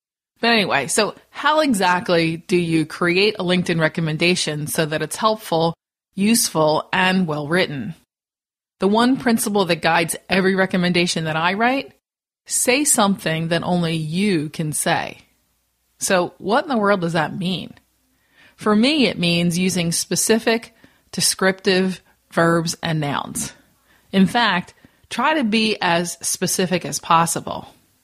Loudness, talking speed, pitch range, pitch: -19 LUFS, 135 wpm, 165-210 Hz, 180 Hz